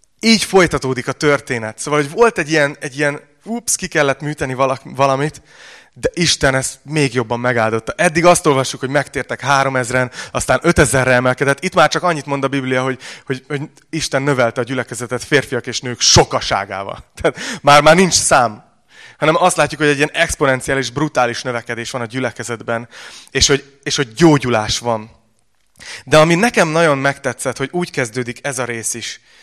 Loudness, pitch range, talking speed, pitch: -15 LUFS, 125-150 Hz, 175 wpm, 135 Hz